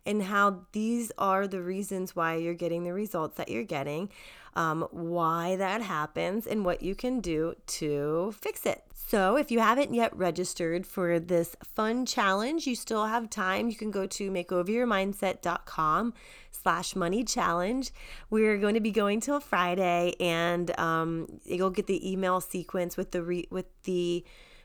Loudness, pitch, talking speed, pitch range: -30 LUFS, 185 Hz, 165 wpm, 175-215 Hz